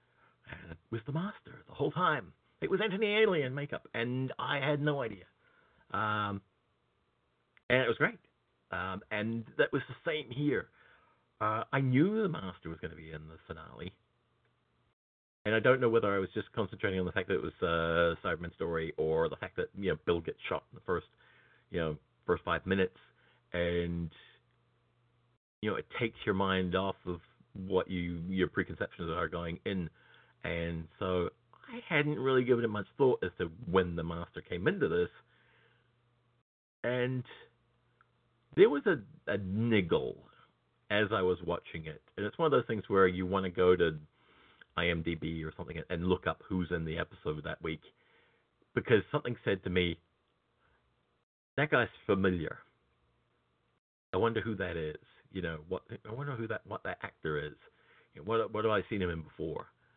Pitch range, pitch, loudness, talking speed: 85-115 Hz, 95 Hz, -33 LUFS, 180 wpm